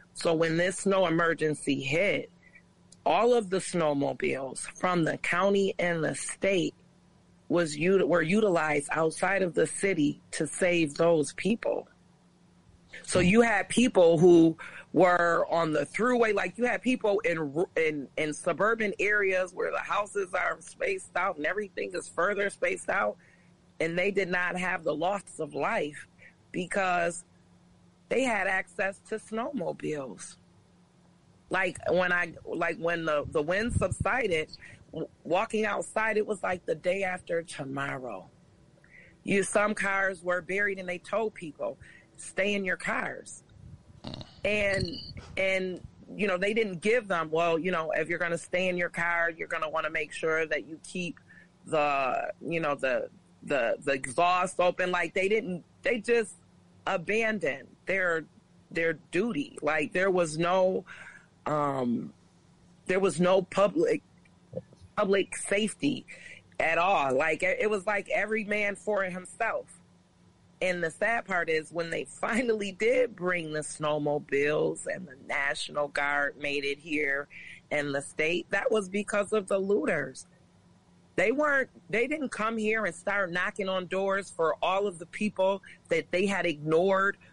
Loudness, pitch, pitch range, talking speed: -28 LUFS, 180 Hz, 165-205 Hz, 150 wpm